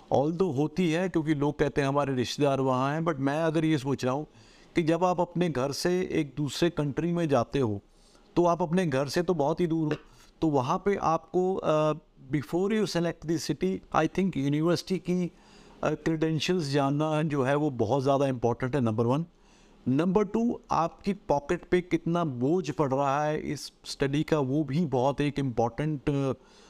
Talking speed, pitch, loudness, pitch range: 190 wpm, 155 Hz, -28 LUFS, 140-175 Hz